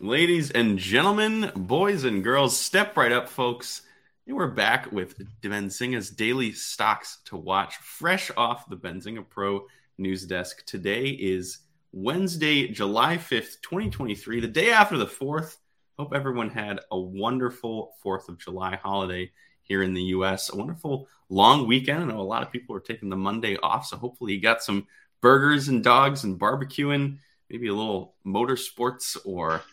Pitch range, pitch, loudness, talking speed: 95-135 Hz, 115 Hz, -25 LUFS, 160 wpm